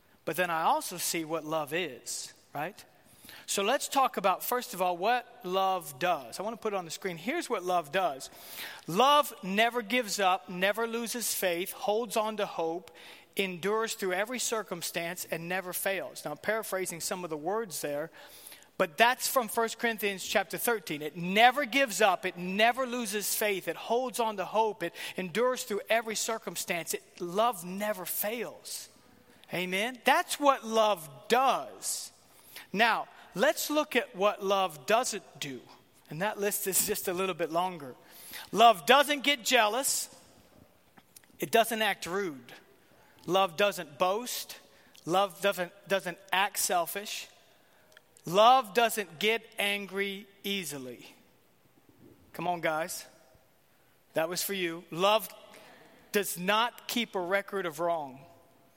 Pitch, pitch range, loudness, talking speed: 200 Hz, 180-230 Hz, -30 LUFS, 145 wpm